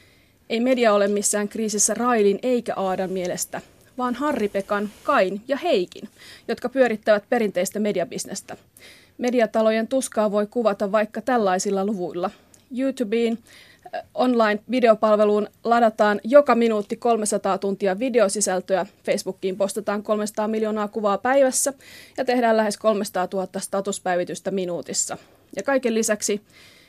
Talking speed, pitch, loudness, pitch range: 110 wpm, 215 Hz, -22 LUFS, 195-235 Hz